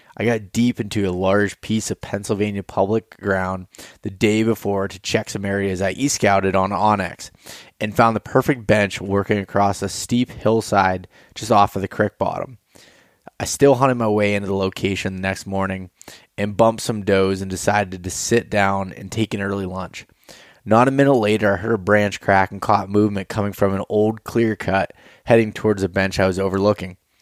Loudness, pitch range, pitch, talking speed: -20 LUFS, 95-110 Hz, 100 Hz, 195 wpm